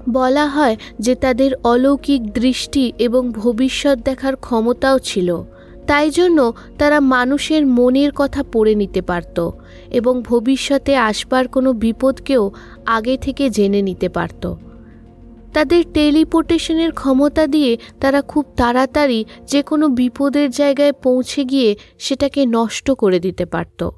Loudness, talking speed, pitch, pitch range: -16 LUFS, 120 wpm, 260 Hz, 230-280 Hz